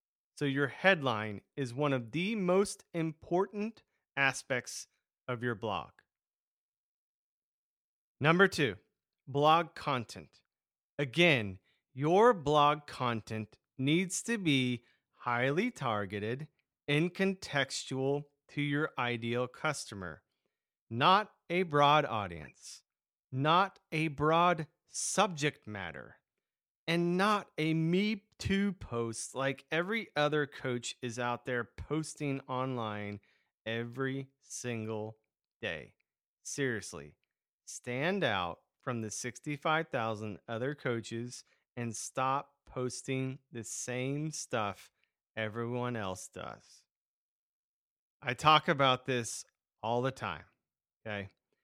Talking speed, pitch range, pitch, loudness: 100 wpm, 115-155 Hz, 135 Hz, -33 LUFS